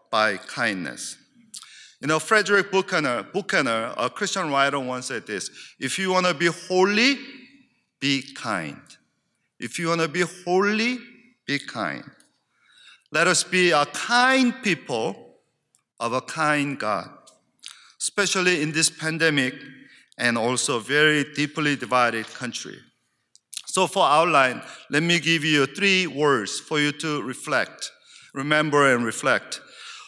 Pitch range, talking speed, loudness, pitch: 145-200 Hz, 130 wpm, -22 LUFS, 165 Hz